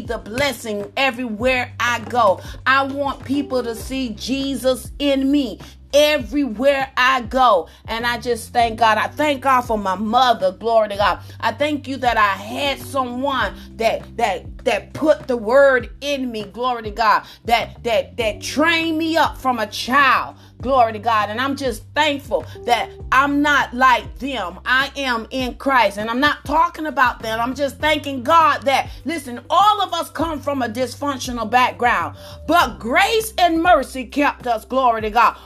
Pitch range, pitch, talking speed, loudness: 240-290 Hz, 265 Hz, 175 wpm, -18 LUFS